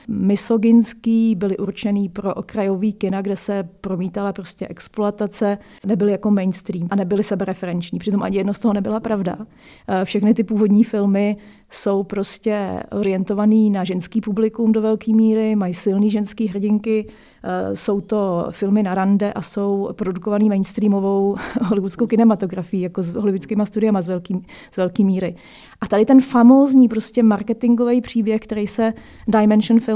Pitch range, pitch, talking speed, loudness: 195-220 Hz, 205 Hz, 140 wpm, -19 LUFS